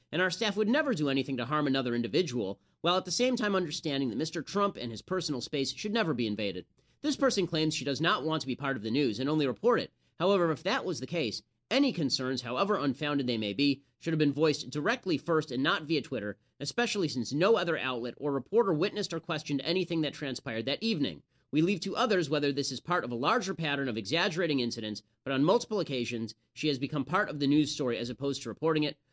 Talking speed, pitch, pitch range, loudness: 235 wpm, 150 Hz, 130-180 Hz, -30 LUFS